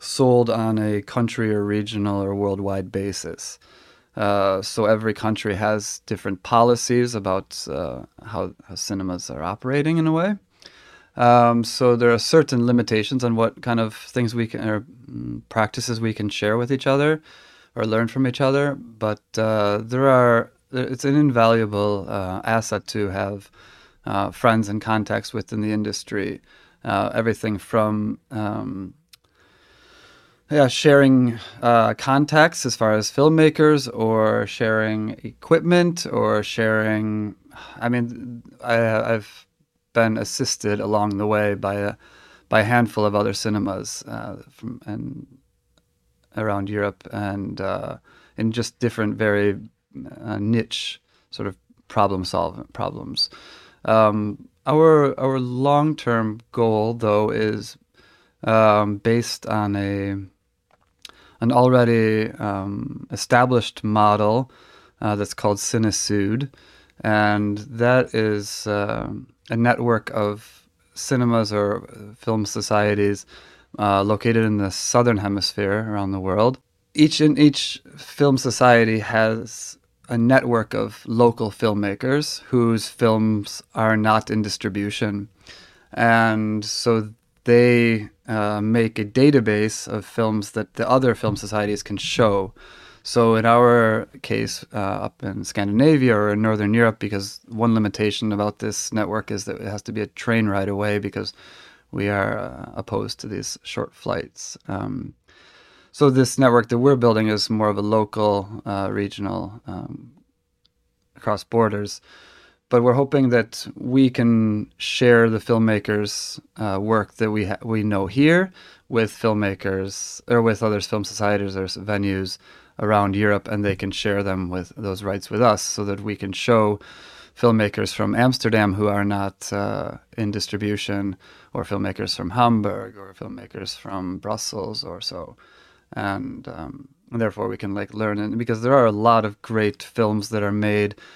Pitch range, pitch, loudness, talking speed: 100-120 Hz, 110 Hz, -21 LUFS, 140 wpm